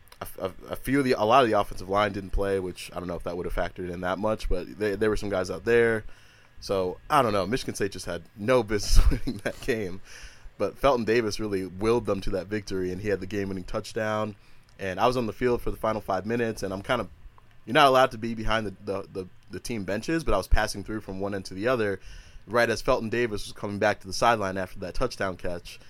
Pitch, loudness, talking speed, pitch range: 105 Hz, -27 LUFS, 260 wpm, 95-115 Hz